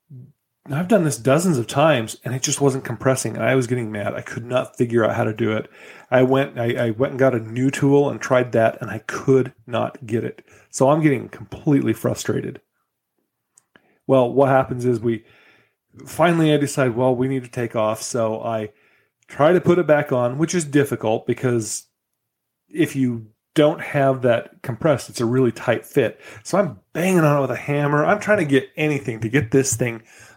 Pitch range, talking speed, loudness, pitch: 120-145 Hz, 205 wpm, -20 LUFS, 130 Hz